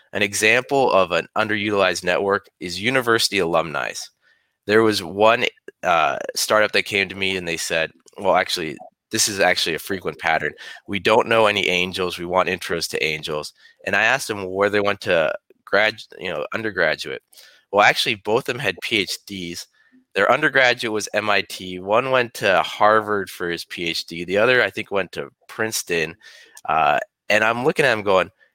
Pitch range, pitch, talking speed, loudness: 90-120 Hz, 105 Hz, 175 wpm, -20 LUFS